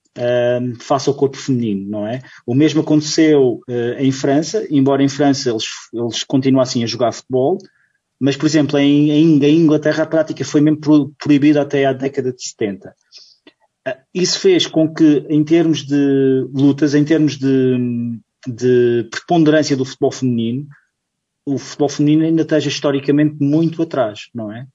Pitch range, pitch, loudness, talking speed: 130-155 Hz, 140 Hz, -15 LUFS, 150 wpm